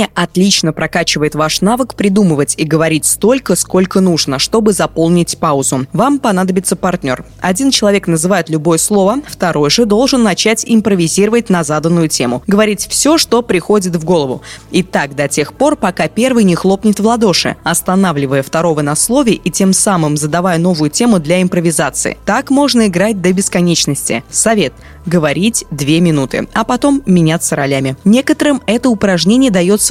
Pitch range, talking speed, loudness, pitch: 160-215 Hz, 150 wpm, -12 LUFS, 185 Hz